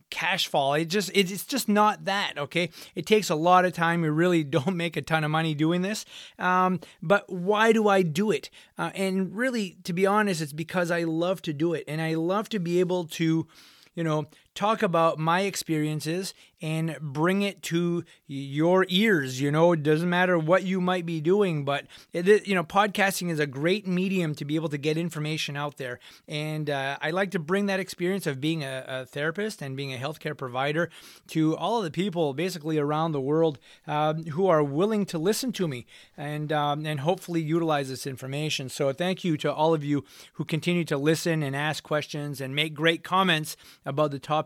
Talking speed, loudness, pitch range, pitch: 210 wpm, -26 LUFS, 150-185 Hz, 165 Hz